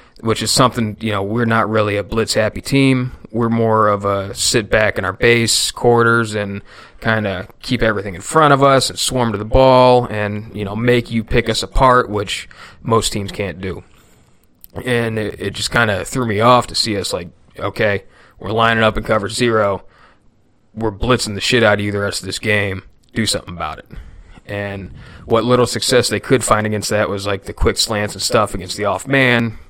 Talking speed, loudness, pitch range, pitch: 210 wpm, -16 LUFS, 100-120 Hz, 110 Hz